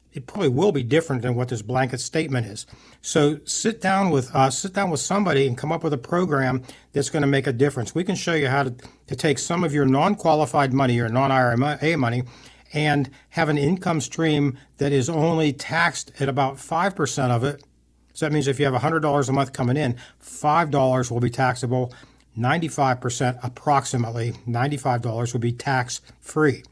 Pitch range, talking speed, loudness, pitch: 125-155 Hz, 190 wpm, -22 LUFS, 140 Hz